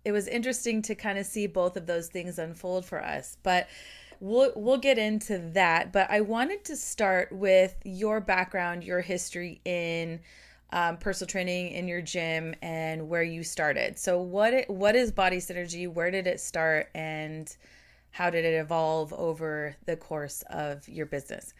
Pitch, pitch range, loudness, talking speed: 180 Hz, 165-200 Hz, -29 LUFS, 175 wpm